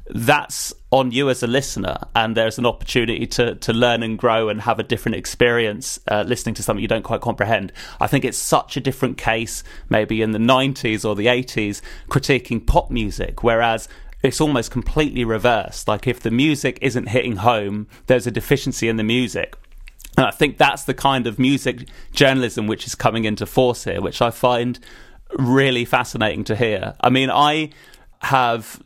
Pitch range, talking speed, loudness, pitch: 110-130 Hz, 190 wpm, -19 LUFS, 120 Hz